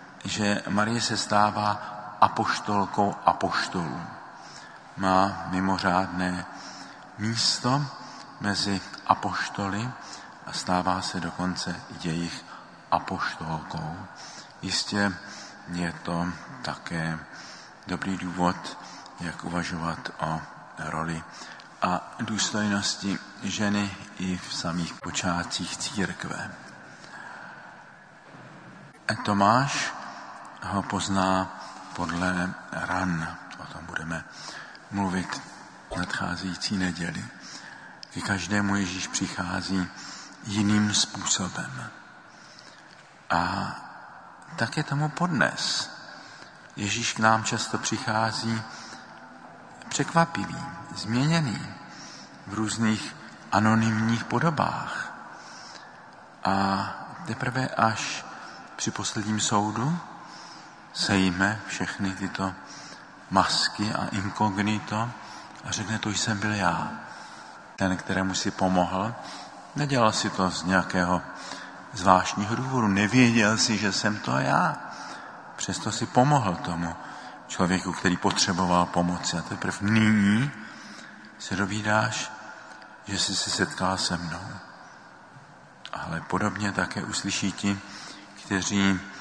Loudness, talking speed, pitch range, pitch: -27 LUFS, 85 wpm, 90-110 Hz, 100 Hz